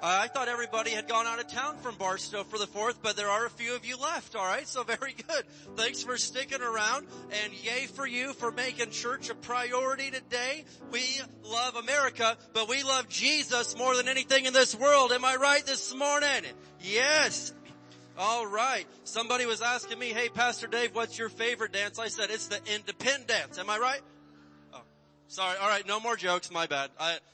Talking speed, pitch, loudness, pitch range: 190 wpm, 235 Hz, -29 LUFS, 210-255 Hz